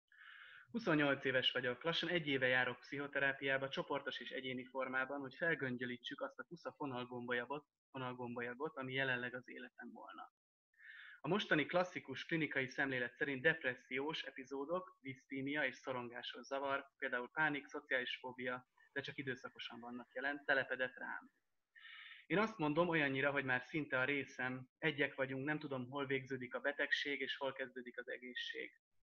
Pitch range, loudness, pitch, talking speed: 130-150 Hz, -41 LUFS, 135 Hz, 140 wpm